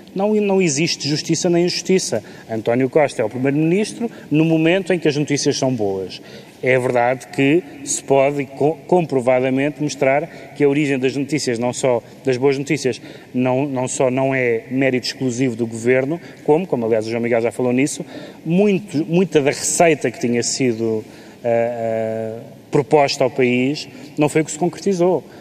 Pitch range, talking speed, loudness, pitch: 125-160 Hz, 170 wpm, -18 LUFS, 140 Hz